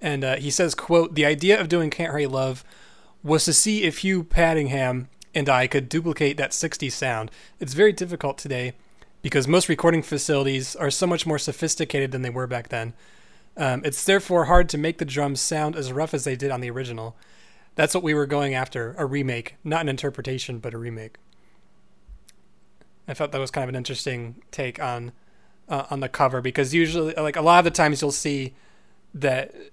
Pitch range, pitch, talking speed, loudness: 130-165 Hz, 145 Hz, 200 wpm, -23 LUFS